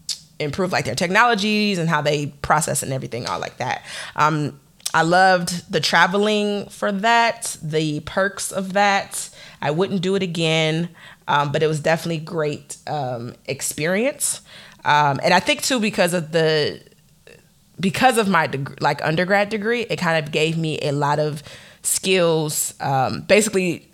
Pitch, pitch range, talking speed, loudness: 165 Hz, 150-195 Hz, 160 wpm, -20 LUFS